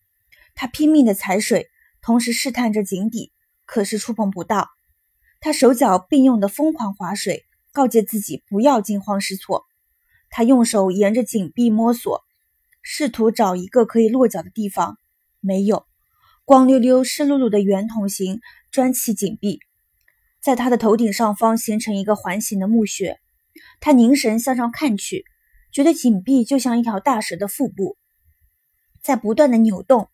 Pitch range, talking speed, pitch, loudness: 205-270 Hz, 235 characters per minute, 230 Hz, -18 LUFS